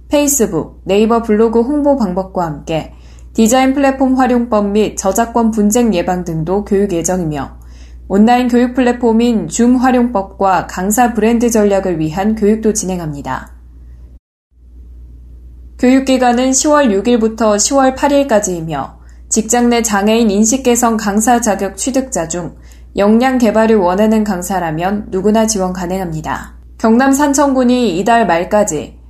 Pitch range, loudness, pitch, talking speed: 175-240 Hz, -13 LUFS, 210 Hz, 290 characters per minute